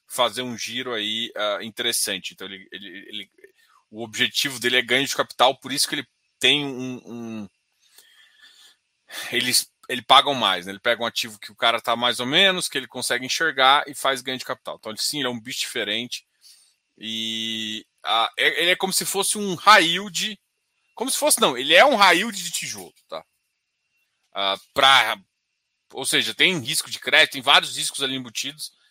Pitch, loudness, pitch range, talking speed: 125 Hz, -20 LUFS, 115-165 Hz, 190 wpm